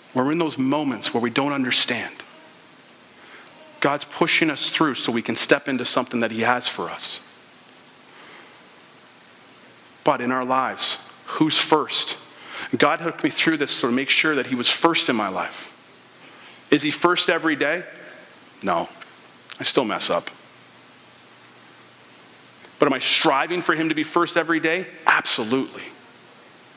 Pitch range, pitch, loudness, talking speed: 125-165 Hz, 150 Hz, -20 LUFS, 150 wpm